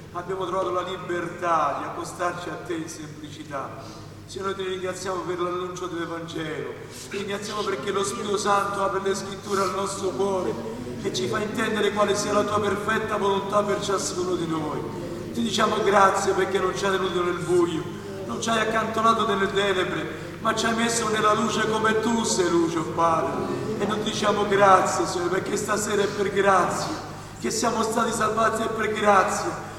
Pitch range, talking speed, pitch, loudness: 175-210 Hz, 180 wpm, 195 Hz, -24 LUFS